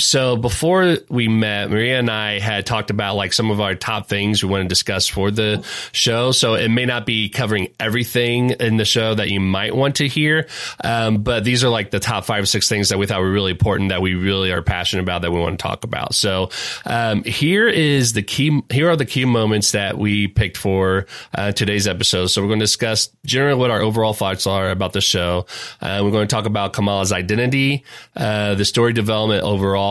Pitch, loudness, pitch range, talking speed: 105 Hz, -18 LUFS, 100-120 Hz, 230 wpm